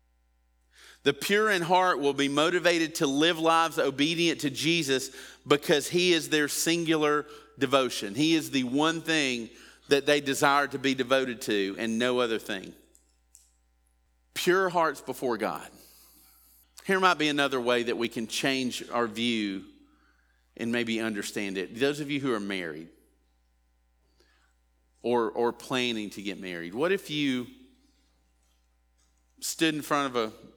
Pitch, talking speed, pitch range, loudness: 130 Hz, 145 wpm, 90-150 Hz, -27 LUFS